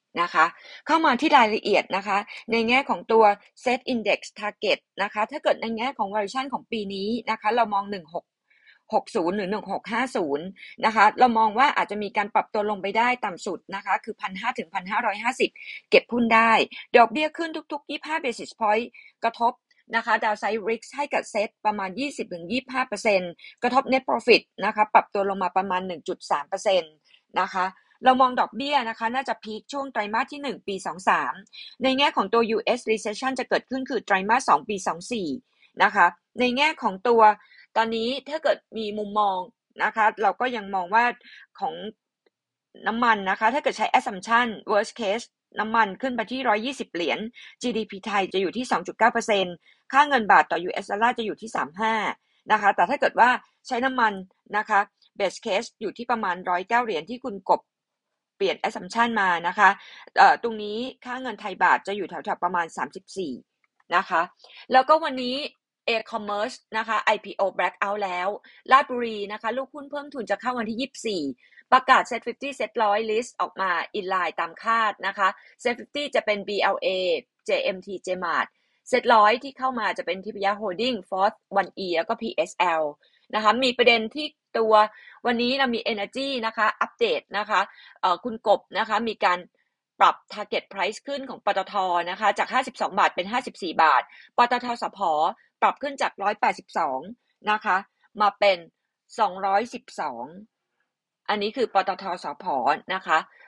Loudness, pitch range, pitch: -24 LUFS, 200-250 Hz, 220 Hz